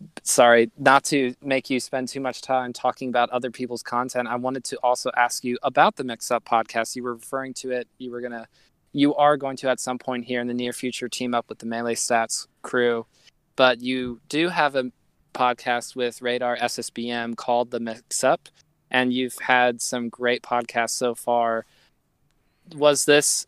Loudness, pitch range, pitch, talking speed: -23 LUFS, 120-130 Hz, 125 Hz, 190 wpm